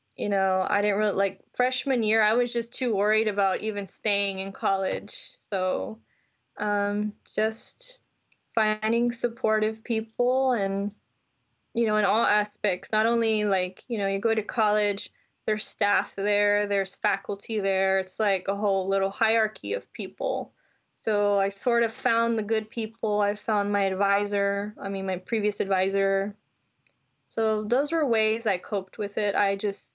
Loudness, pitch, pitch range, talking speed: -26 LUFS, 210 Hz, 200-225 Hz, 160 wpm